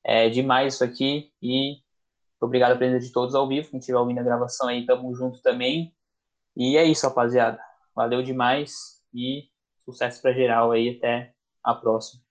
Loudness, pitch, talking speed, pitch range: -23 LUFS, 125 Hz, 170 wpm, 120-135 Hz